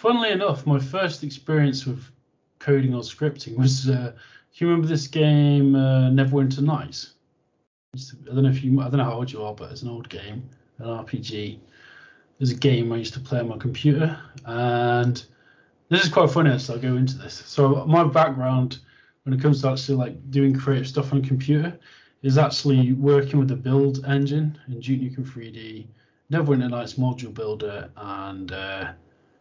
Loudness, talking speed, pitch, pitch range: -22 LUFS, 180 wpm, 130 Hz, 120-145 Hz